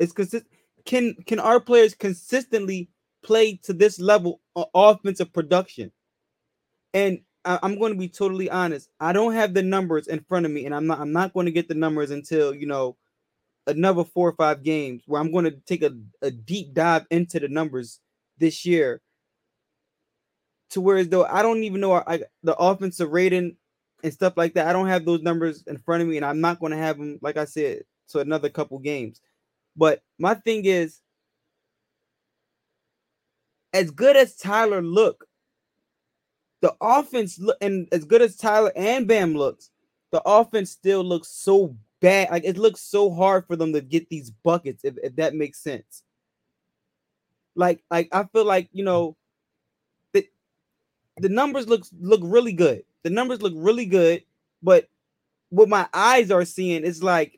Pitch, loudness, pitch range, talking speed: 180 Hz, -22 LUFS, 160-205 Hz, 180 wpm